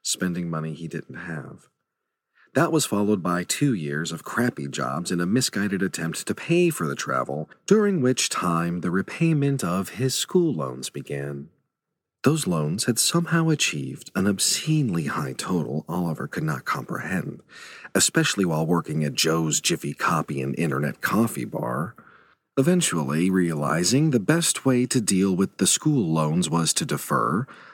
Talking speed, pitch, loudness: 155 wpm, 95 Hz, -24 LUFS